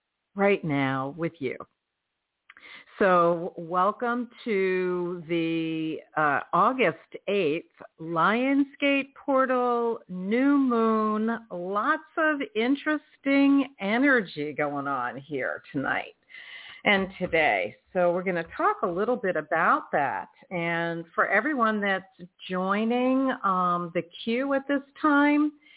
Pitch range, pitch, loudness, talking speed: 175-265 Hz, 205 Hz, -26 LUFS, 105 wpm